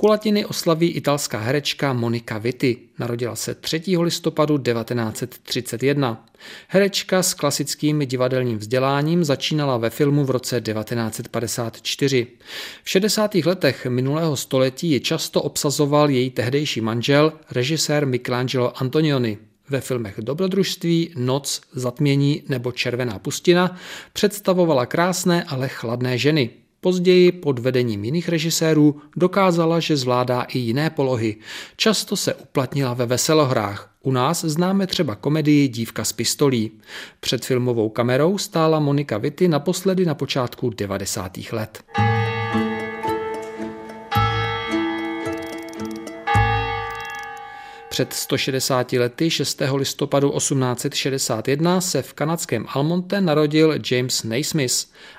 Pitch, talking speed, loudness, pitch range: 140 Hz, 105 wpm, -21 LUFS, 120-165 Hz